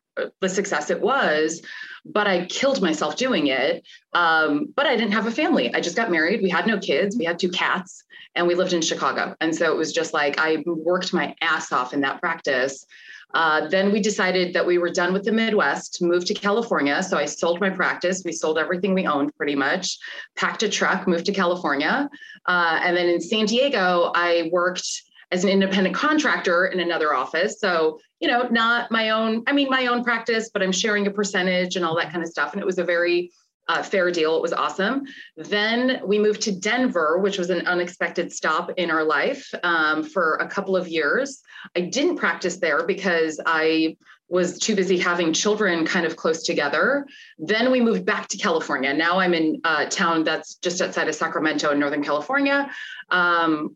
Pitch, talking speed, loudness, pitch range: 185 Hz, 205 wpm, -22 LUFS, 170-215 Hz